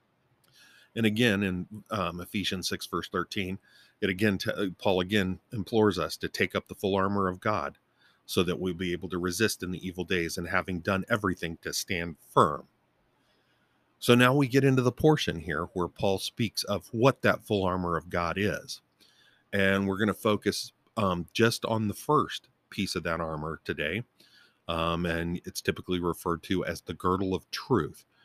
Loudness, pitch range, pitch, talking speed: -29 LUFS, 90-105 Hz, 95 Hz, 185 wpm